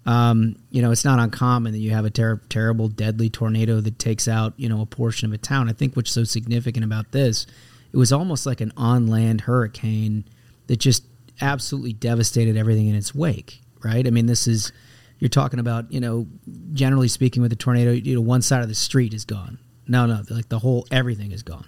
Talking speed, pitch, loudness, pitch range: 220 wpm, 120 Hz, -21 LUFS, 110-125 Hz